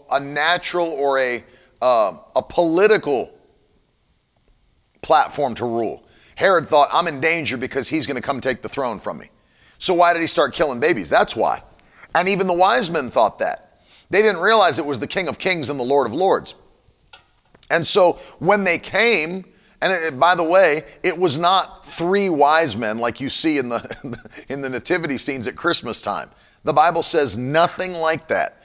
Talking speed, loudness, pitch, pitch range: 190 wpm, -19 LUFS, 160 Hz, 130-175 Hz